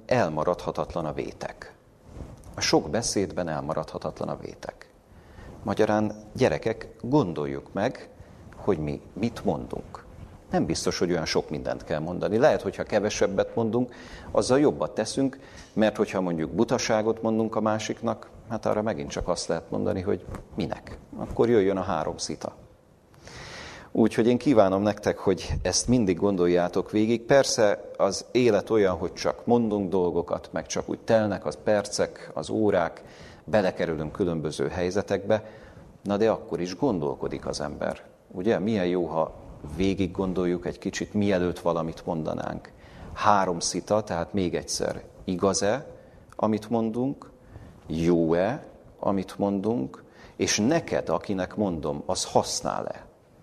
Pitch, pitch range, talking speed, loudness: 100 Hz, 90-110 Hz, 130 wpm, -26 LUFS